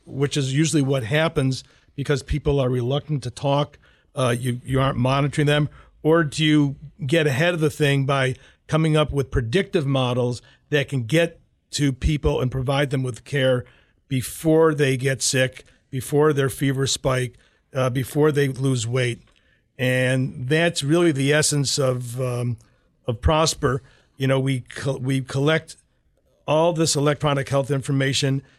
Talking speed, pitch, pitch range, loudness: 155 wpm, 140 Hz, 130-150 Hz, -22 LUFS